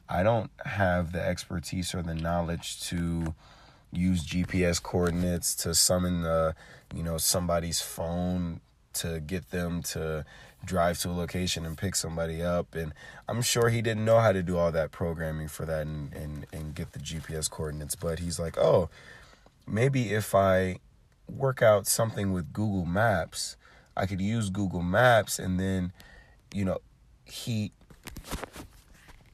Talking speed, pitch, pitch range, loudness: 155 wpm, 85 Hz, 80-95 Hz, -29 LUFS